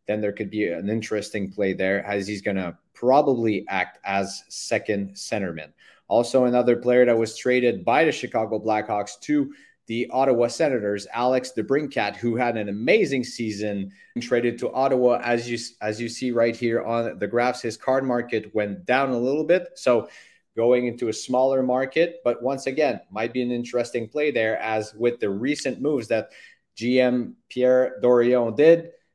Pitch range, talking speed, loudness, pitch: 105-130 Hz, 175 wpm, -23 LUFS, 120 Hz